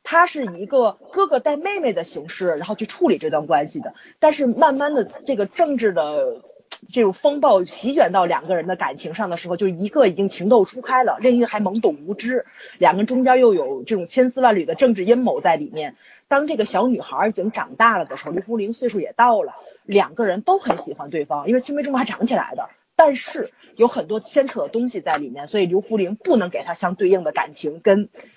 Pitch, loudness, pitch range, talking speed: 240 Hz, -19 LUFS, 200-285 Hz, 335 characters per minute